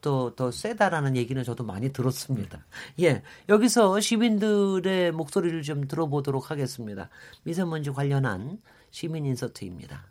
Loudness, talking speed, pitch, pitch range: -26 LUFS, 335 characters per minute, 145 Hz, 130-185 Hz